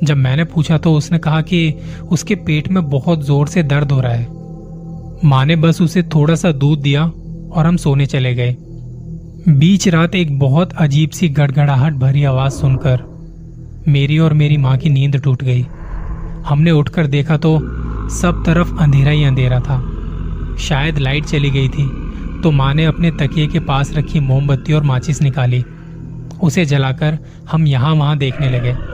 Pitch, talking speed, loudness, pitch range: 150 Hz, 170 wpm, -14 LUFS, 135-160 Hz